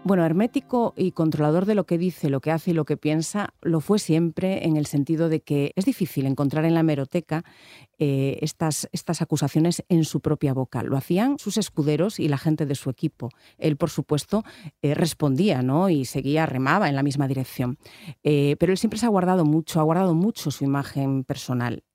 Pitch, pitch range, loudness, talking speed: 155 Hz, 145-175 Hz, -23 LUFS, 200 wpm